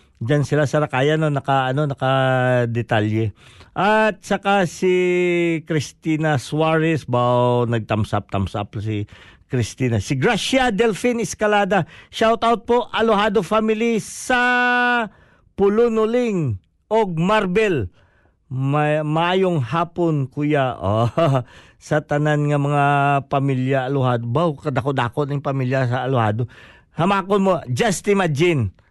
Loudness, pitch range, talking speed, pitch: -19 LUFS, 125-195 Hz, 115 wpm, 150 Hz